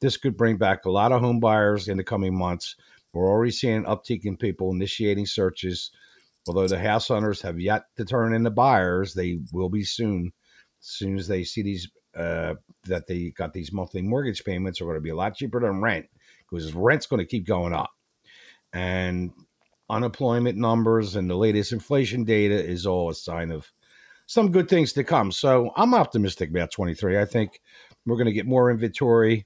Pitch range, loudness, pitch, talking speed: 90-115 Hz, -24 LUFS, 105 Hz, 195 wpm